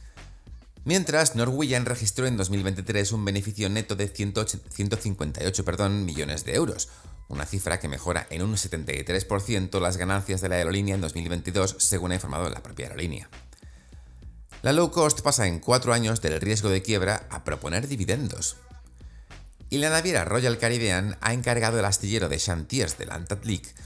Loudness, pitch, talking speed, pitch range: -26 LUFS, 95 Hz, 160 wpm, 85-110 Hz